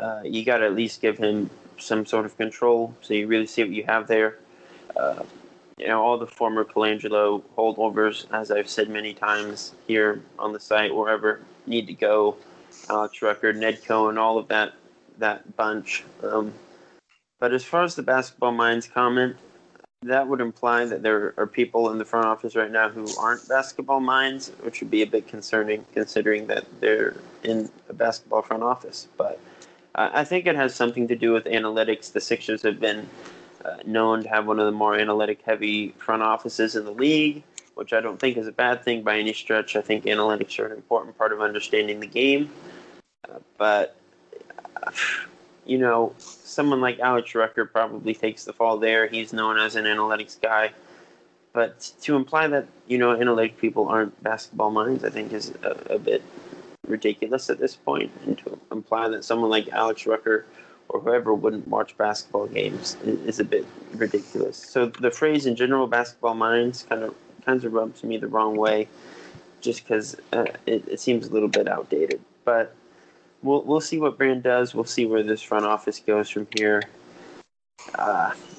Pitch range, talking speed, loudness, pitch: 110-125 Hz, 185 wpm, -24 LUFS, 110 Hz